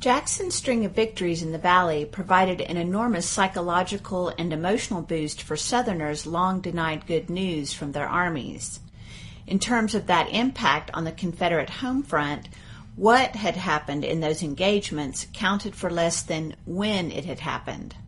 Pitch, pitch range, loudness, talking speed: 175 Hz, 155-200 Hz, -25 LUFS, 155 wpm